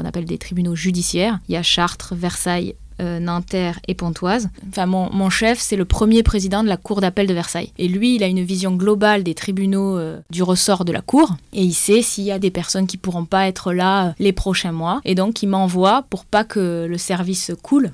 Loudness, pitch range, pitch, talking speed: -19 LUFS, 175-200 Hz, 185 Hz, 235 wpm